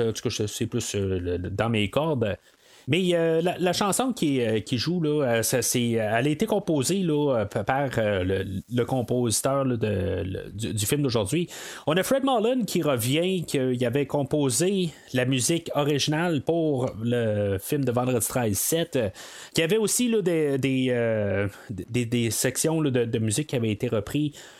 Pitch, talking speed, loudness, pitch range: 130 Hz, 140 wpm, -25 LUFS, 115-160 Hz